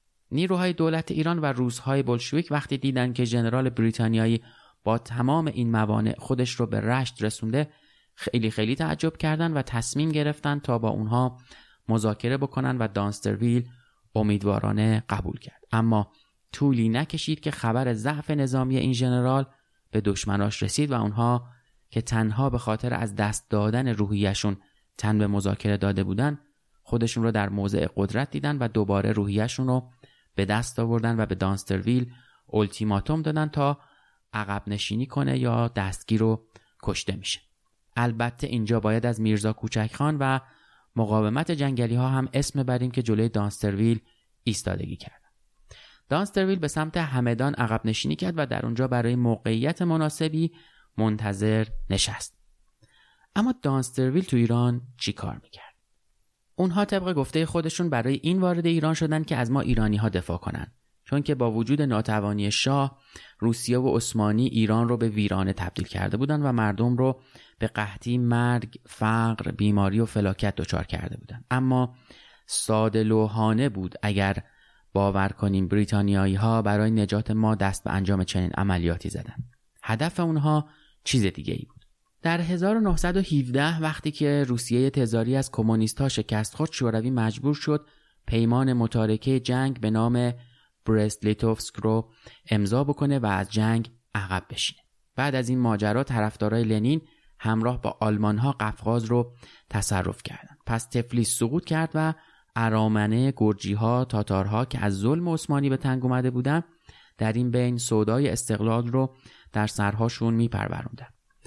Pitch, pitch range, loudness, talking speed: 120 Hz, 110-135 Hz, -26 LUFS, 145 wpm